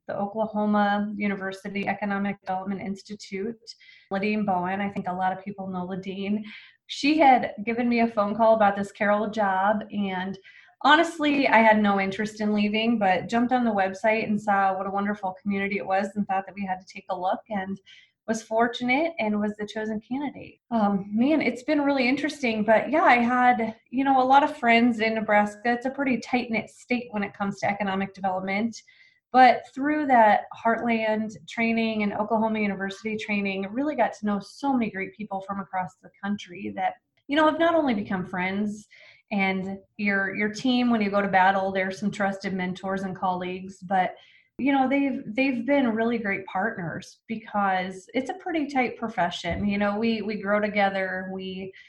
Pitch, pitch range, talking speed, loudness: 210 Hz, 195-235 Hz, 185 wpm, -25 LUFS